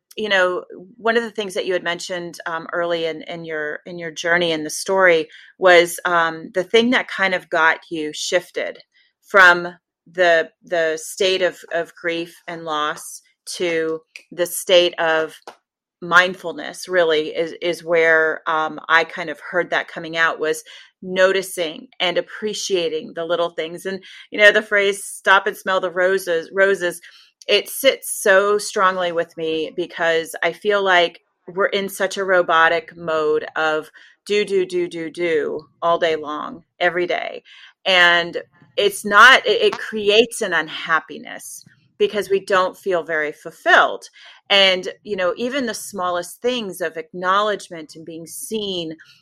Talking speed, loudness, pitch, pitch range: 155 wpm, -18 LUFS, 175 Hz, 165-195 Hz